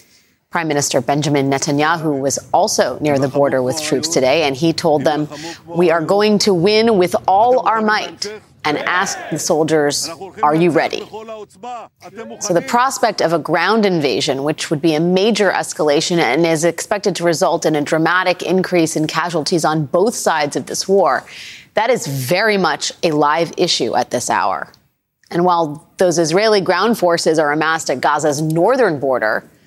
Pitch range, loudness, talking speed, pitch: 150-190 Hz, -16 LUFS, 170 wpm, 170 Hz